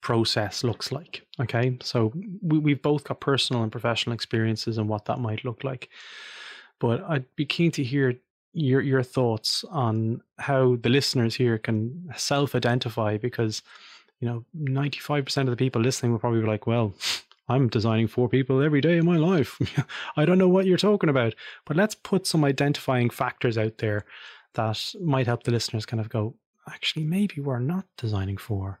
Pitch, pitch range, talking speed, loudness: 125 Hz, 115-145 Hz, 185 wpm, -25 LUFS